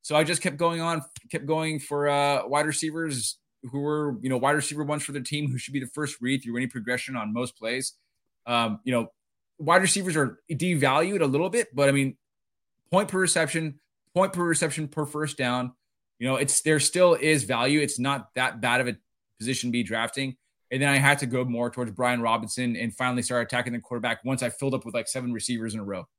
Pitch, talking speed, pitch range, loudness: 135 Hz, 230 wpm, 120-150 Hz, -26 LUFS